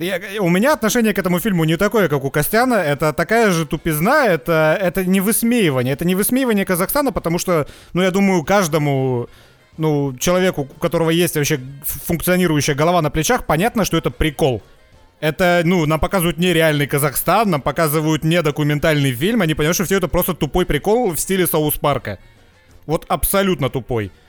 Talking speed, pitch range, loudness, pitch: 170 wpm, 150-190 Hz, -17 LUFS, 170 Hz